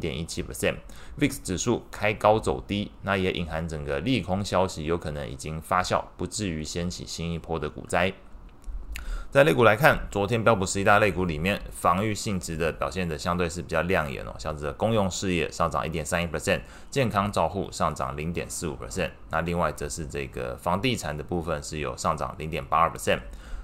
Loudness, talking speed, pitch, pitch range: -27 LUFS, 360 characters per minute, 85 Hz, 75-95 Hz